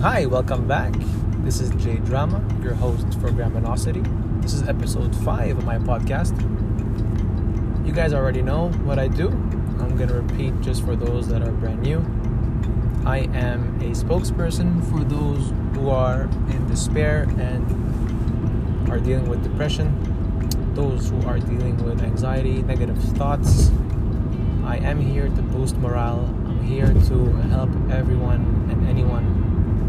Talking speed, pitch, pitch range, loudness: 145 wpm, 110 Hz, 105-115 Hz, -22 LUFS